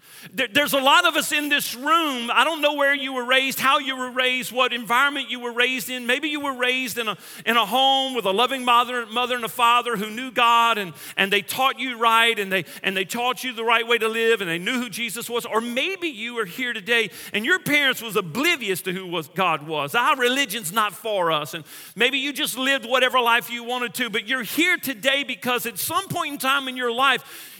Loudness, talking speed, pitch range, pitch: -21 LUFS, 240 wpm, 230-270 Hz, 245 Hz